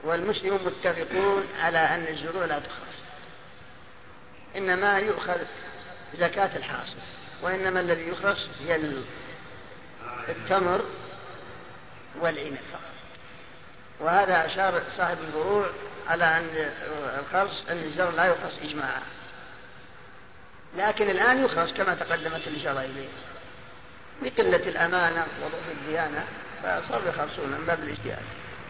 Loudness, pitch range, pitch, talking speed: -27 LUFS, 160-195 Hz, 170 Hz, 90 wpm